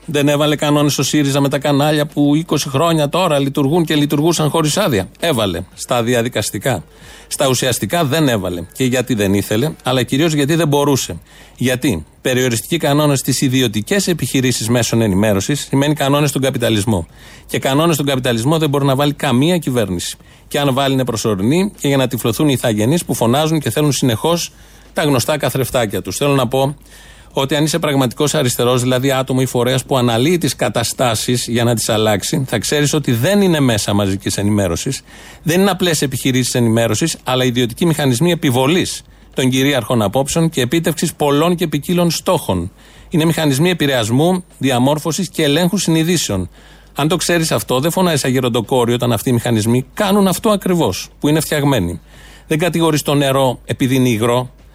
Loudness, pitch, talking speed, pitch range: -15 LUFS, 140 Hz, 165 wpm, 120-155 Hz